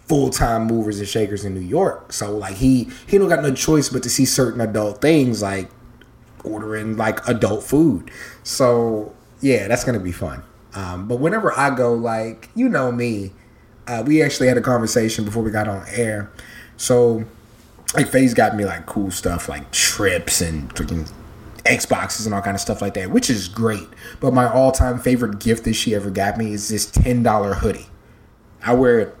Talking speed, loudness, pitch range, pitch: 190 wpm, -19 LUFS, 100-125 Hz, 115 Hz